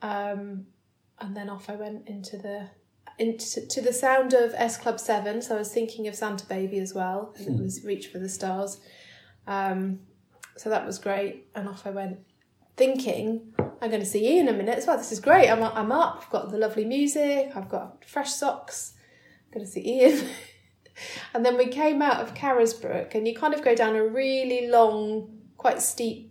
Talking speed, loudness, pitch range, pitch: 205 wpm, -26 LUFS, 200-250 Hz, 225 Hz